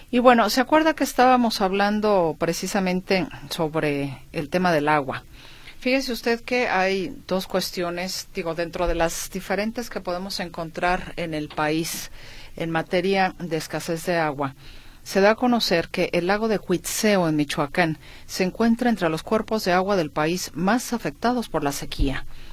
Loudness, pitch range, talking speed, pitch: -23 LUFS, 160-210 Hz, 165 wpm, 180 Hz